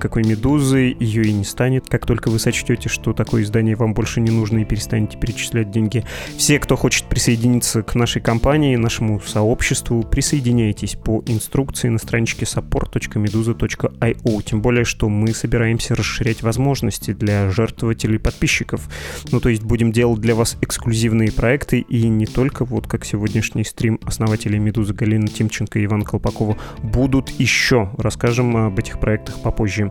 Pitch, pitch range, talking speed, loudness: 115 Hz, 110-120 Hz, 155 wpm, -18 LUFS